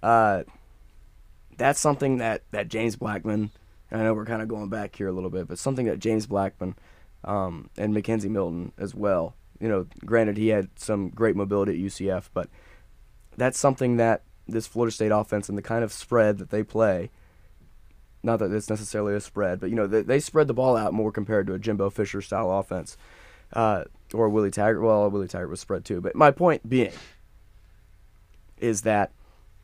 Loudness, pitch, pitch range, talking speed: -26 LUFS, 105 Hz, 95-110 Hz, 190 wpm